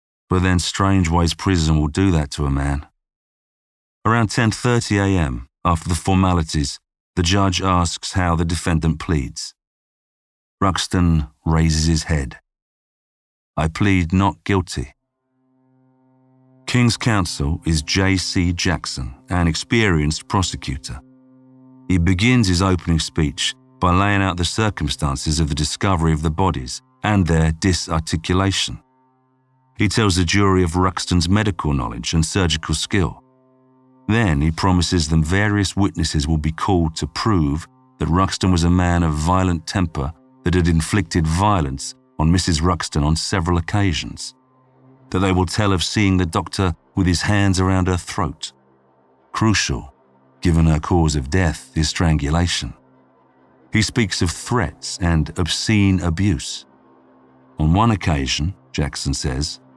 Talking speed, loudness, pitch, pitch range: 135 wpm, -19 LUFS, 90 Hz, 80-100 Hz